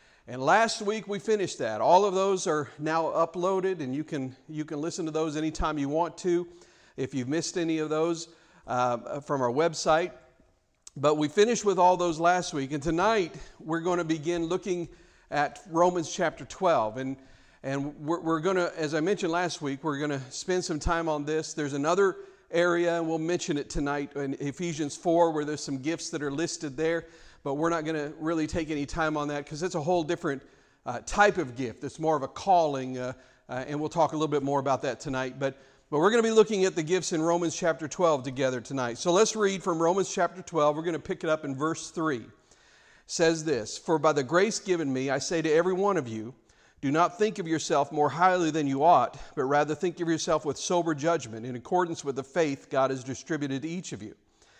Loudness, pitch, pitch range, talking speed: -28 LUFS, 160 Hz, 145-175 Hz, 225 wpm